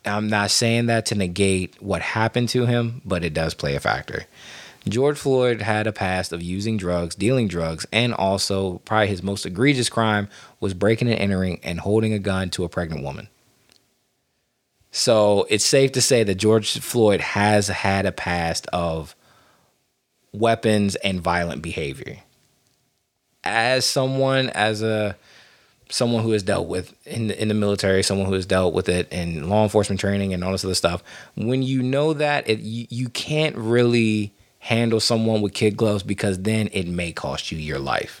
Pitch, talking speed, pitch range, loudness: 105 Hz, 175 wpm, 95-115 Hz, -21 LUFS